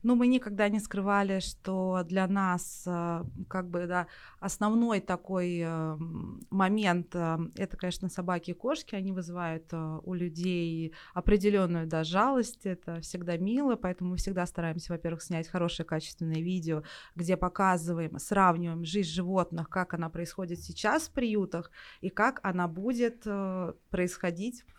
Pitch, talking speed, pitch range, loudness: 180 Hz, 135 wpm, 170-195 Hz, -31 LUFS